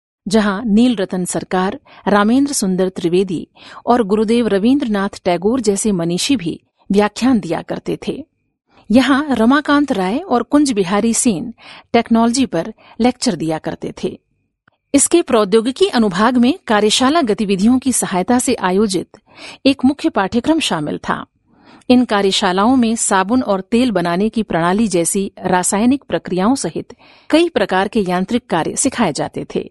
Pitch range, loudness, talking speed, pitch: 195-250 Hz, -16 LUFS, 135 wpm, 220 Hz